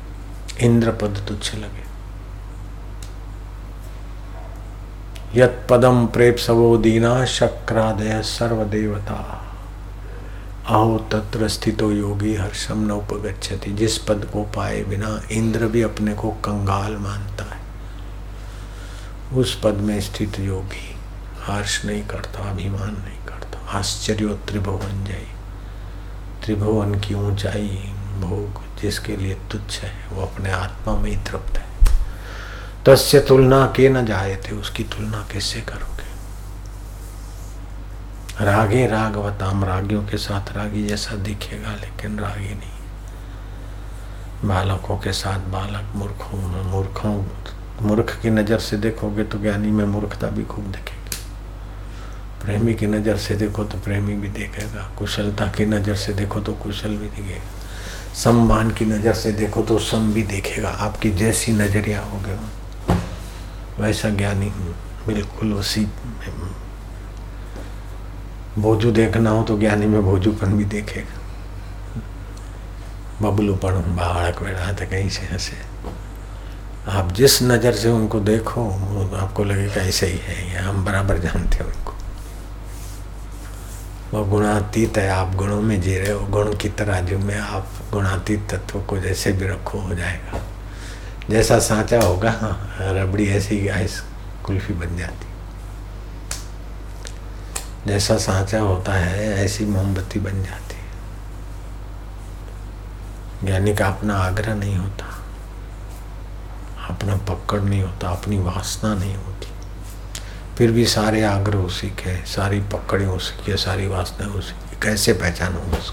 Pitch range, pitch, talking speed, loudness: 95-105 Hz, 100 Hz, 120 wpm, -21 LUFS